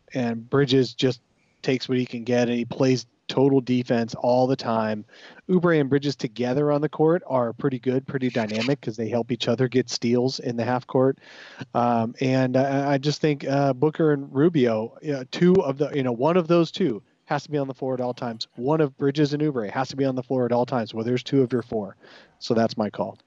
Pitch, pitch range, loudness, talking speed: 130 Hz, 120-145 Hz, -24 LUFS, 235 wpm